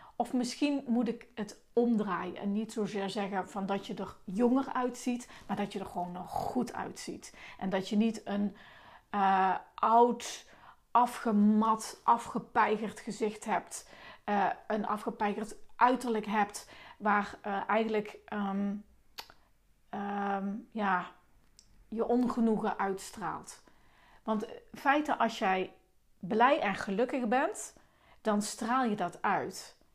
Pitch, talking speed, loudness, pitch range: 215 Hz, 125 wpm, -32 LUFS, 200-235 Hz